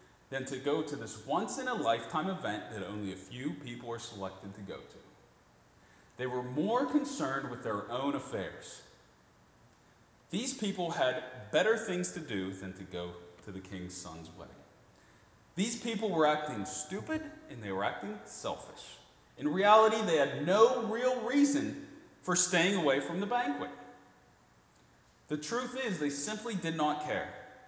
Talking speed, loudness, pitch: 160 wpm, -33 LUFS, 150 Hz